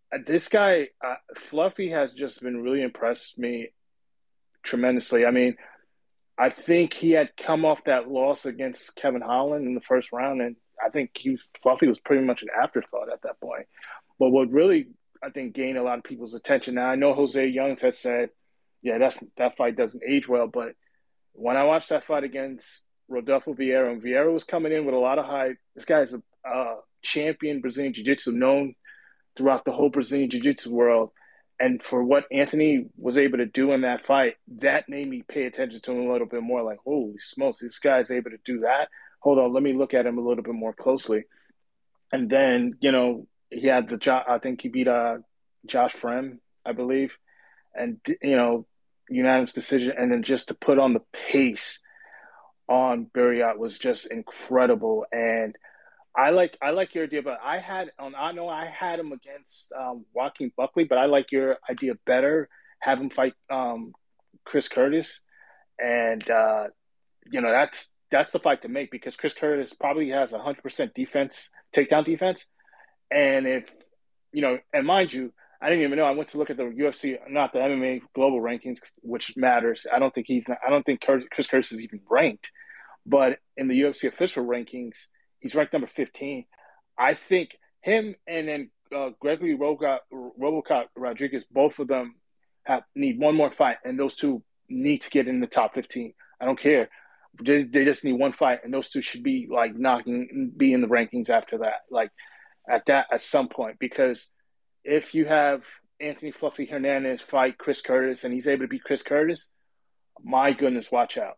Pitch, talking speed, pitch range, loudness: 135 Hz, 195 wpm, 125-155 Hz, -25 LUFS